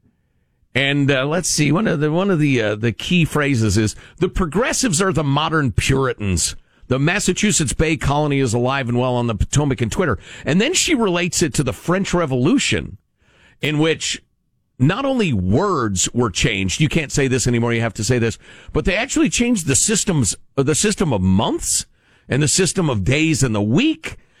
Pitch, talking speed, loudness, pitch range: 140 Hz, 190 wpm, -18 LUFS, 120-175 Hz